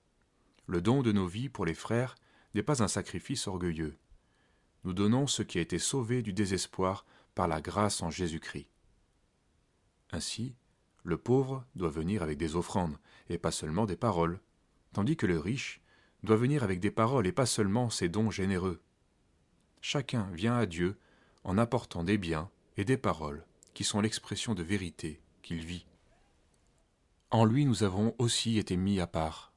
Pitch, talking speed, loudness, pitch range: 100 Hz, 165 wpm, -32 LUFS, 85-115 Hz